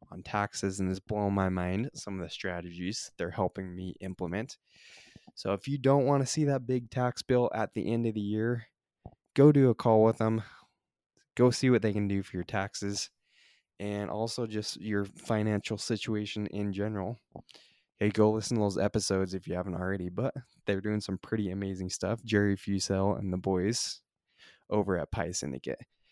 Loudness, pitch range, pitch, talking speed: -31 LUFS, 95-115 Hz, 105 Hz, 185 wpm